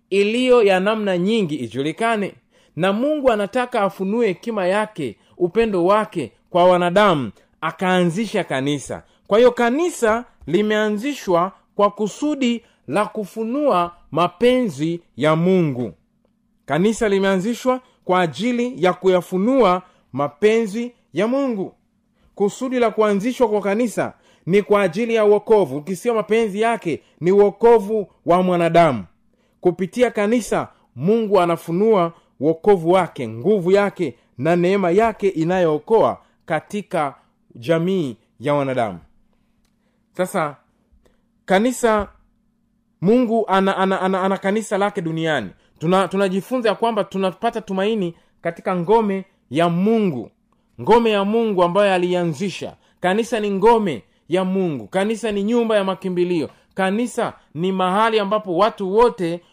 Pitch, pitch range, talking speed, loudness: 200 Hz, 175-225 Hz, 115 wpm, -19 LUFS